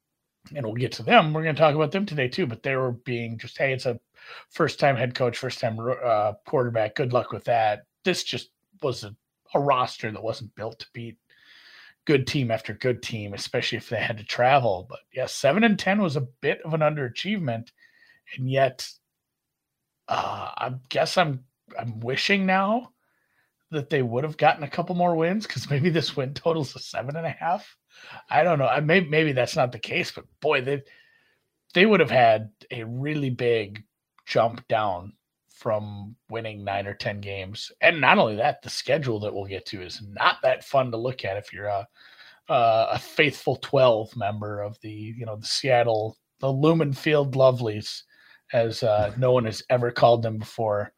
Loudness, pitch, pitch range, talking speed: -24 LUFS, 125 Hz, 110-150 Hz, 195 wpm